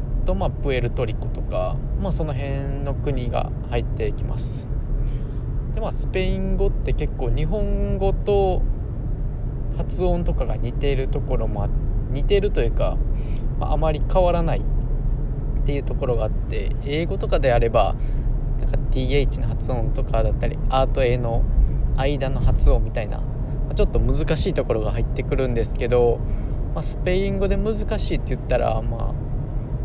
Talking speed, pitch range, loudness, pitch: 325 characters per minute, 115-135 Hz, -24 LUFS, 125 Hz